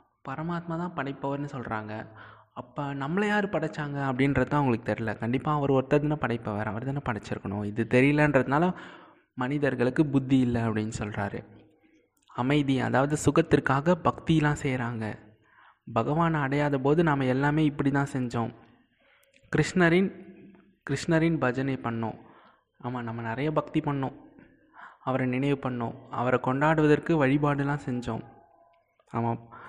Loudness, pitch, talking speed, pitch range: -27 LUFS, 135 Hz, 110 wpm, 115-150 Hz